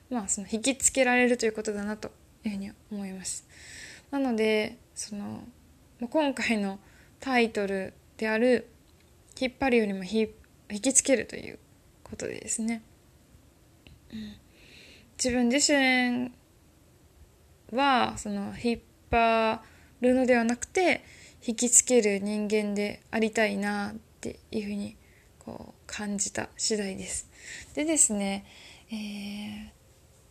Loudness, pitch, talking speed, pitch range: -27 LUFS, 220 Hz, 235 characters per minute, 205-245 Hz